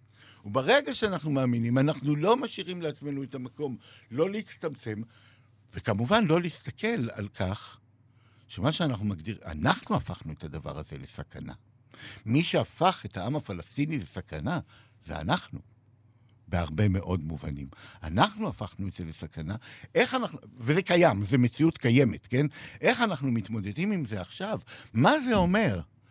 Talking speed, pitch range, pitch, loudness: 135 wpm, 105-155 Hz, 120 Hz, -28 LUFS